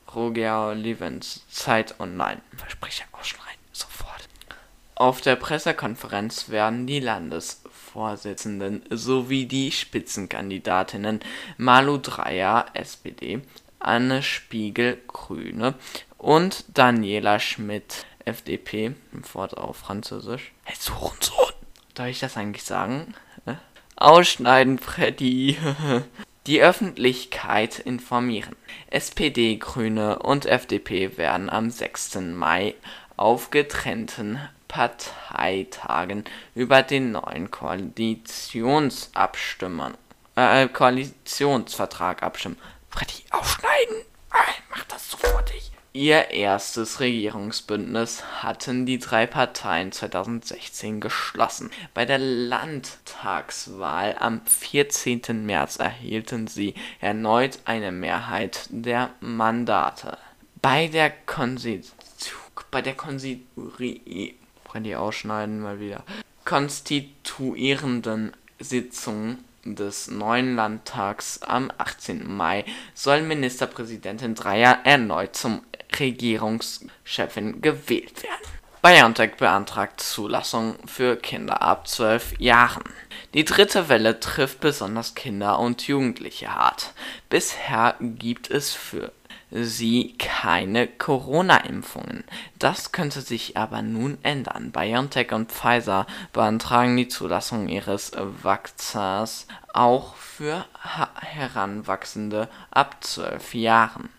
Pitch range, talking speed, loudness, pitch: 110-130 Hz, 90 wpm, -23 LUFS, 120 Hz